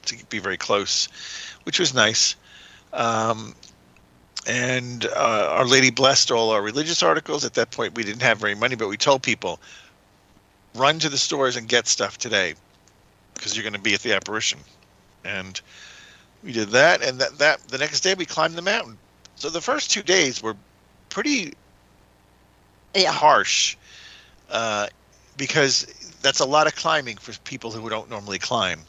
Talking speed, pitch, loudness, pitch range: 170 wpm, 120 Hz, -21 LUFS, 105-145 Hz